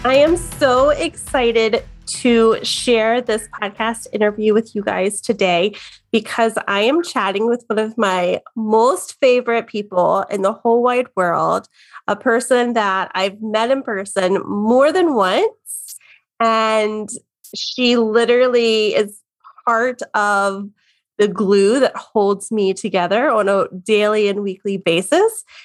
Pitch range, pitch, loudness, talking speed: 205-240 Hz, 220 Hz, -17 LUFS, 135 wpm